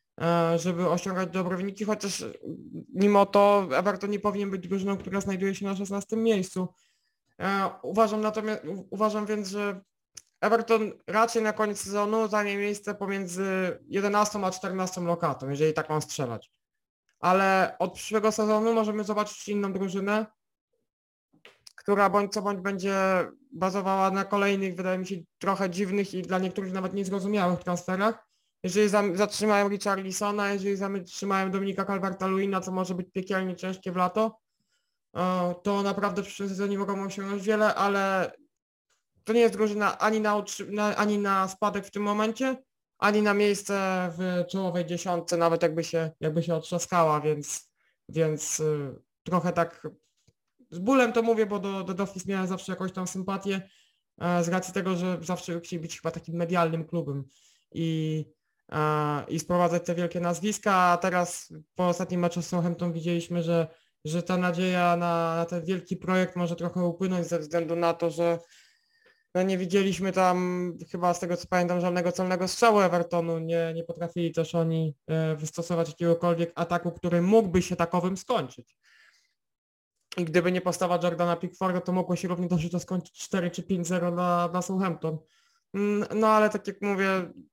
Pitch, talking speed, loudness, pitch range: 185 Hz, 150 wpm, -27 LUFS, 175-200 Hz